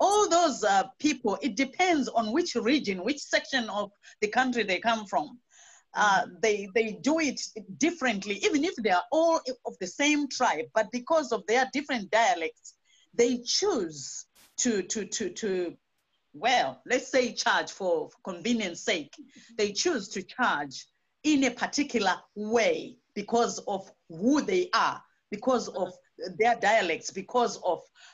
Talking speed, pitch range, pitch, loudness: 150 wpm, 205-285 Hz, 235 Hz, -28 LUFS